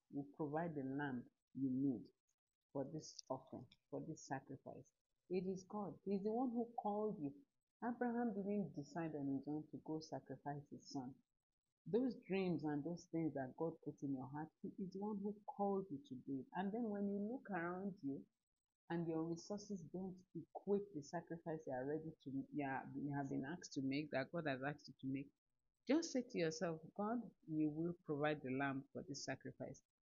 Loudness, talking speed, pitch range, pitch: -46 LUFS, 200 wpm, 140-195 Hz, 160 Hz